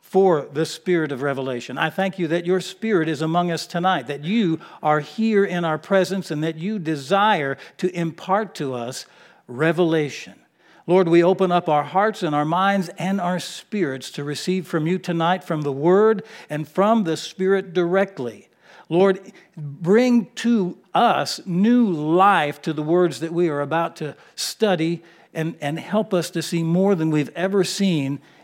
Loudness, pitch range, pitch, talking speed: -21 LUFS, 155-190 Hz, 175 Hz, 175 wpm